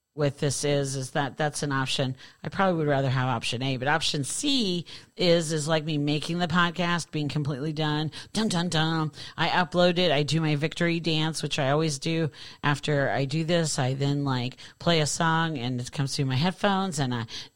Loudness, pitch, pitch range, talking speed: -26 LUFS, 150 Hz, 140-165 Hz, 210 wpm